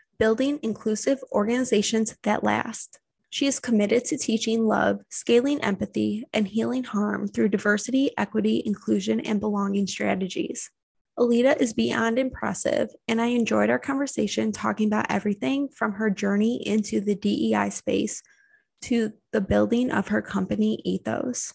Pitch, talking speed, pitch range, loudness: 220 Hz, 135 wpm, 200-245 Hz, -25 LUFS